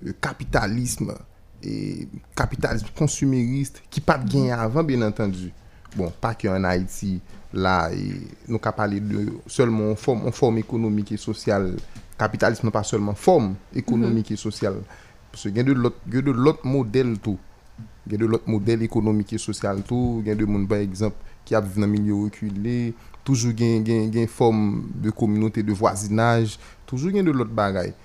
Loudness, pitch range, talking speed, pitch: -23 LUFS, 105-120 Hz, 150 wpm, 110 Hz